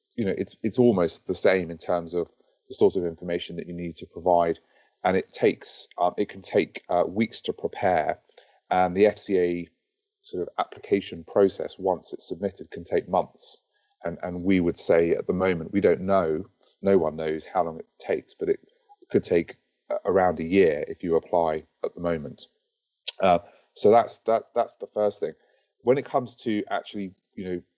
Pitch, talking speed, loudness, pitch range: 95 Hz, 190 wpm, -26 LUFS, 85-115 Hz